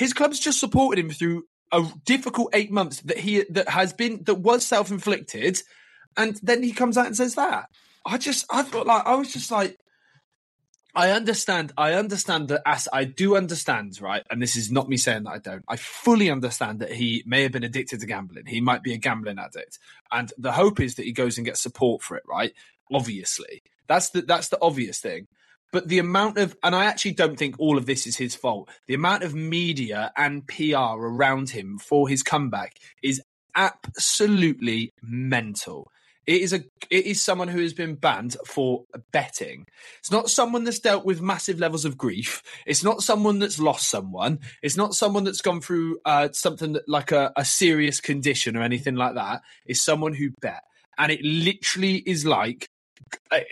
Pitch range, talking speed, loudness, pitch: 135-200 Hz, 195 wpm, -24 LUFS, 165 Hz